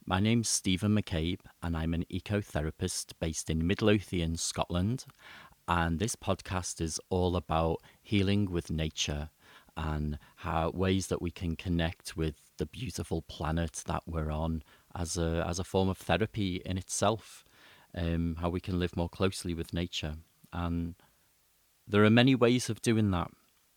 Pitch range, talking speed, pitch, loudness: 80-95 Hz, 155 wpm, 85 Hz, -32 LUFS